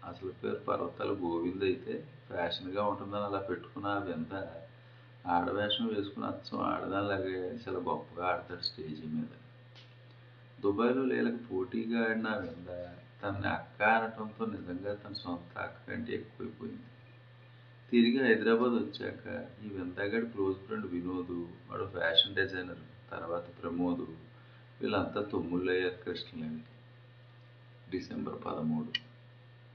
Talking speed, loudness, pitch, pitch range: 105 wpm, -34 LUFS, 105 Hz, 90-120 Hz